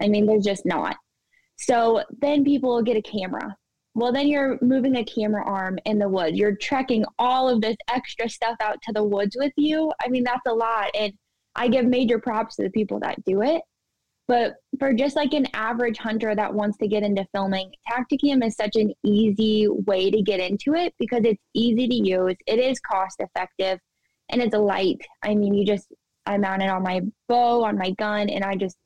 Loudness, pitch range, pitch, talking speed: -23 LUFS, 200-245 Hz, 220 Hz, 210 wpm